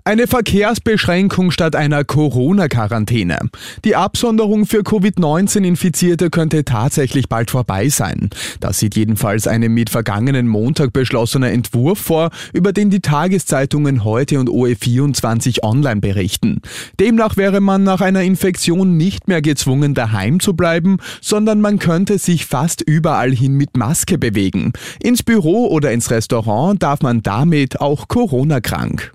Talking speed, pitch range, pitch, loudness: 135 wpm, 120-185 Hz, 150 Hz, -15 LUFS